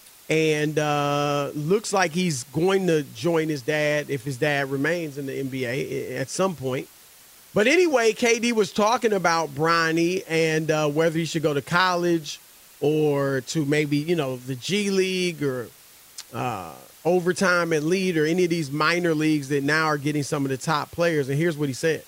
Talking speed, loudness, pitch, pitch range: 185 wpm, -23 LUFS, 155 Hz, 145-175 Hz